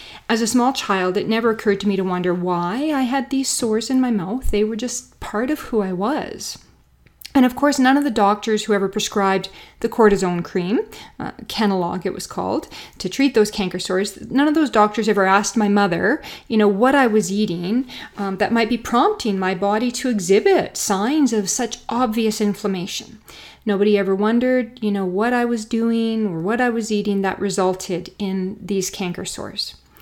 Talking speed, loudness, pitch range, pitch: 195 wpm, -20 LUFS, 195-245 Hz, 215 Hz